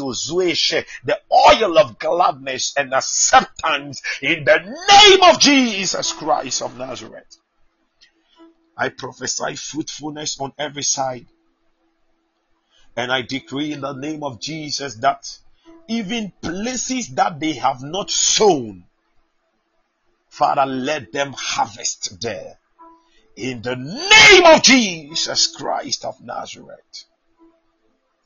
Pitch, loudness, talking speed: 165 Hz, -16 LUFS, 105 wpm